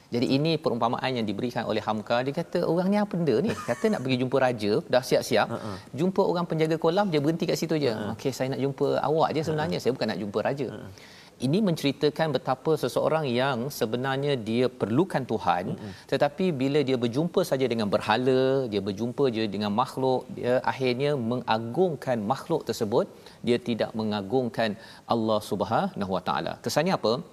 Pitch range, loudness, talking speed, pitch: 120-155 Hz, -26 LUFS, 165 wpm, 130 Hz